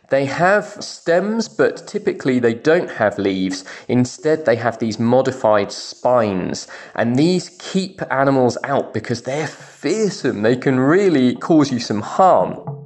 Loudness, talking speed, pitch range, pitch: -18 LUFS, 140 wpm, 115-170 Hz, 135 Hz